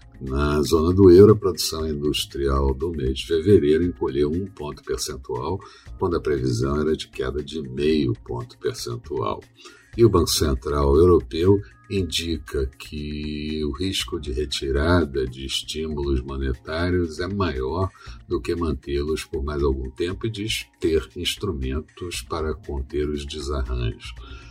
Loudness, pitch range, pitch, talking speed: -23 LUFS, 70-90 Hz, 75 Hz, 135 wpm